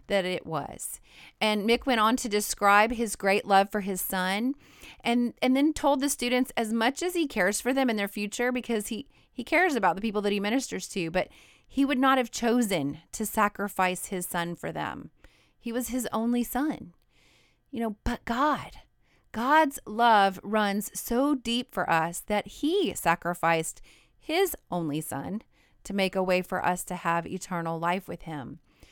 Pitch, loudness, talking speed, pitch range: 215 Hz, -27 LUFS, 185 wpm, 185-250 Hz